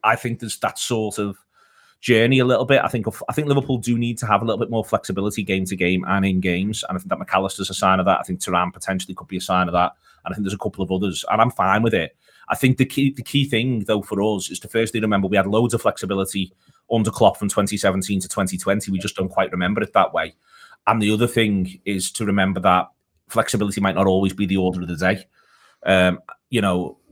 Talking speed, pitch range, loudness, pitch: 255 wpm, 95-115 Hz, -21 LUFS, 100 Hz